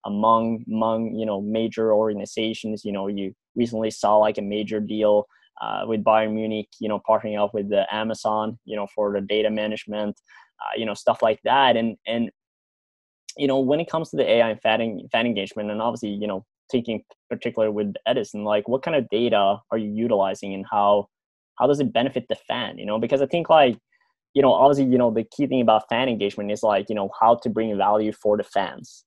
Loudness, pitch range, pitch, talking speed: -23 LUFS, 105-115 Hz, 110 Hz, 215 wpm